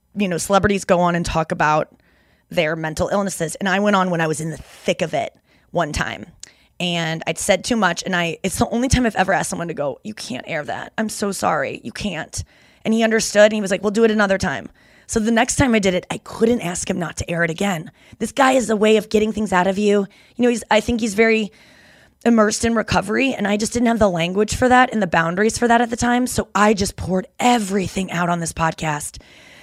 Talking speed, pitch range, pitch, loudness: 255 wpm, 175-225 Hz, 205 Hz, -19 LUFS